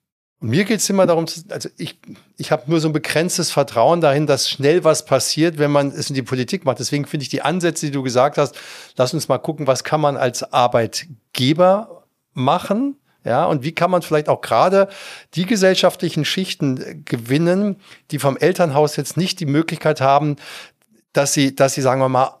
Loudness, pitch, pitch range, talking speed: -18 LUFS, 150 Hz, 140-175 Hz, 195 wpm